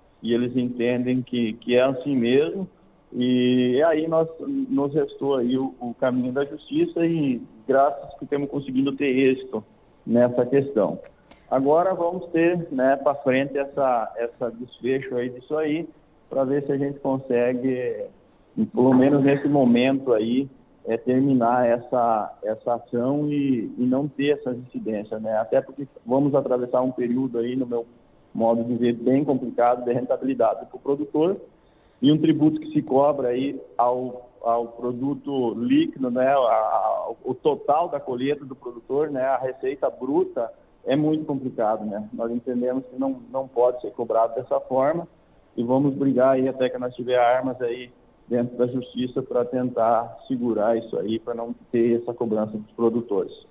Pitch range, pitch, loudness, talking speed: 120-140 Hz, 130 Hz, -23 LUFS, 165 wpm